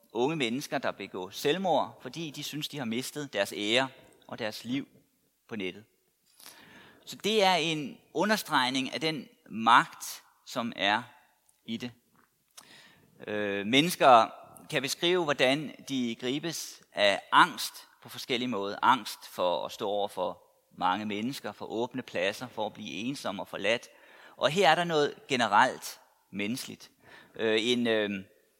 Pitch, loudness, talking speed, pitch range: 135 Hz, -29 LUFS, 145 wpm, 115-170 Hz